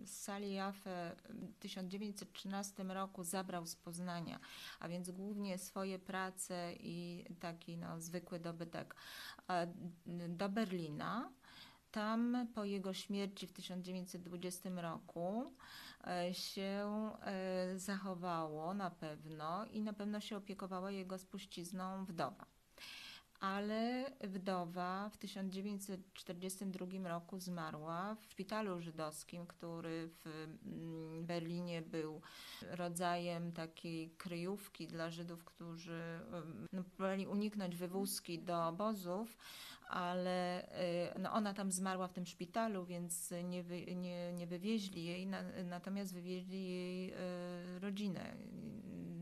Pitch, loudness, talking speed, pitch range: 185 Hz, -45 LUFS, 100 wpm, 175-195 Hz